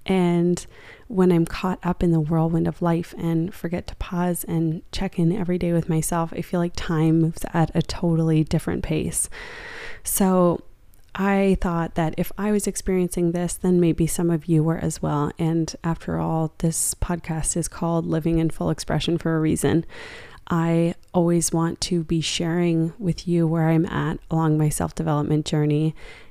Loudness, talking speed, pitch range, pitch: -23 LUFS, 180 wpm, 160-175 Hz, 170 Hz